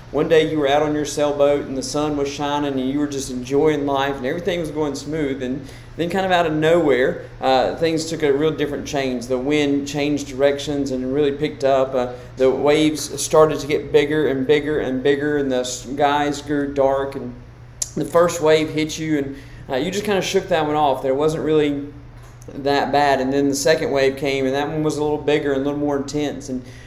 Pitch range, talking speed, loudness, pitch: 135-150 Hz, 230 wpm, -20 LUFS, 145 Hz